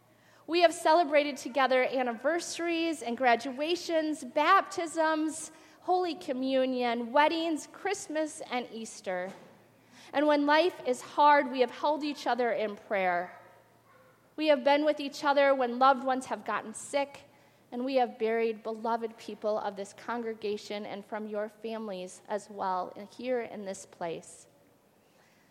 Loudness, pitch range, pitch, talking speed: -30 LUFS, 220-300 Hz, 260 Hz, 135 wpm